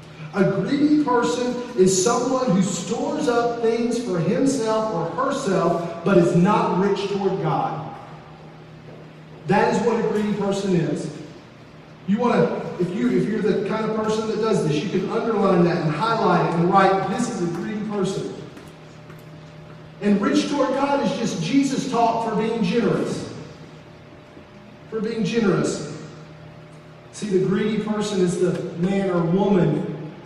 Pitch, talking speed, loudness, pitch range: 200 Hz, 155 wpm, -21 LUFS, 180-225 Hz